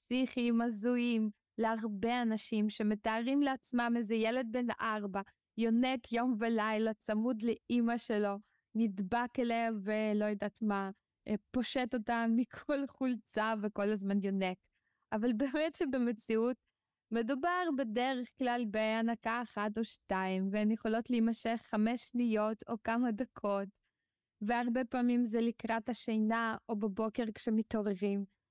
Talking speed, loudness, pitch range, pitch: 110 wpm, -35 LUFS, 215-245 Hz, 230 Hz